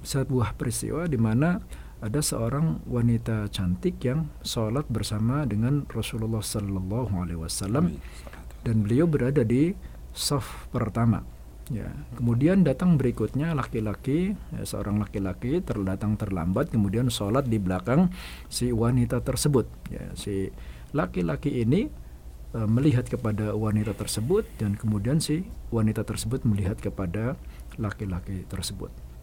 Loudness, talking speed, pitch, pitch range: -27 LUFS, 115 wpm, 110 Hz, 100-130 Hz